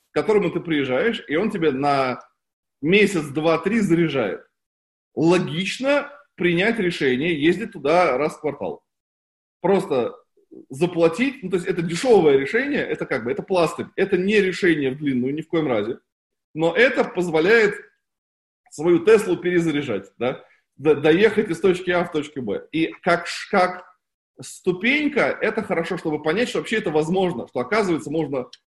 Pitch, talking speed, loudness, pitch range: 175 Hz, 150 wpm, -21 LUFS, 160-210 Hz